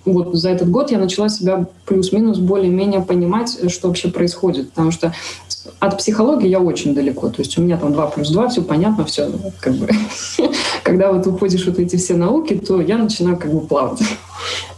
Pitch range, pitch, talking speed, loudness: 175-195 Hz, 185 Hz, 190 wpm, -17 LUFS